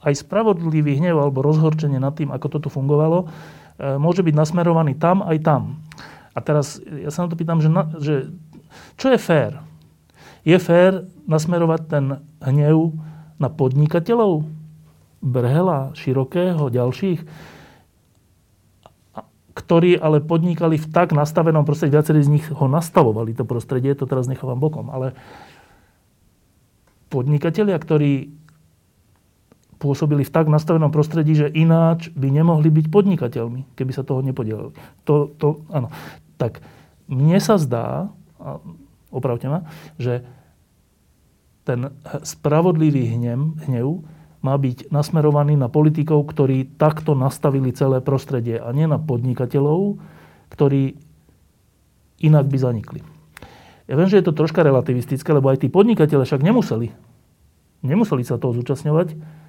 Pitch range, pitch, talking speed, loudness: 135-160 Hz, 150 Hz, 125 wpm, -19 LUFS